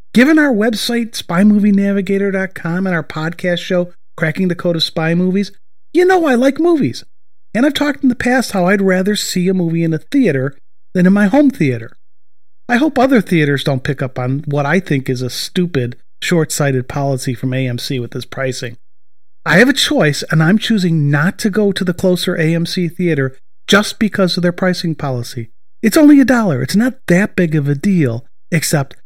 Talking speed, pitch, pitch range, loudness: 195 wpm, 180 Hz, 145-210 Hz, -14 LUFS